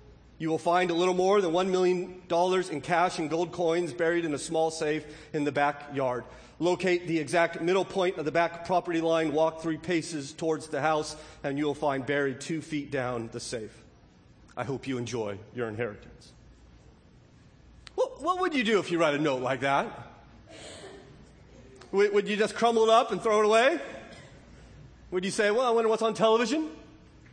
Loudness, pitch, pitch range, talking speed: -28 LUFS, 165 Hz, 150-185 Hz, 185 wpm